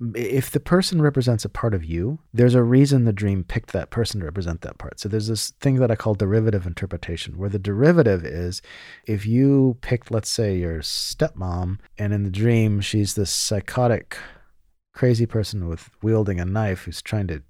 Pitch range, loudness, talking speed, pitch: 95-120 Hz, -22 LUFS, 190 wpm, 110 Hz